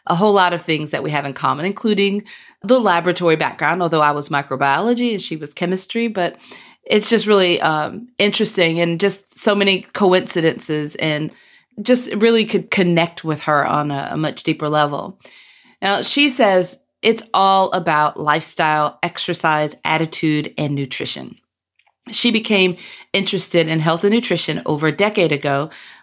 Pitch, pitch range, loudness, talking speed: 175 Hz, 155-205 Hz, -17 LUFS, 155 wpm